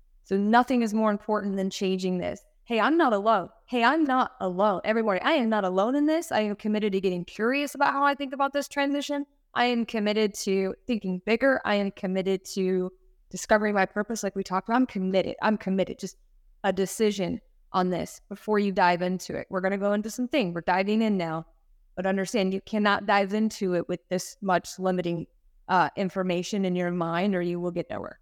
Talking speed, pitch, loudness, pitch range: 210 wpm, 200 Hz, -26 LUFS, 185-225 Hz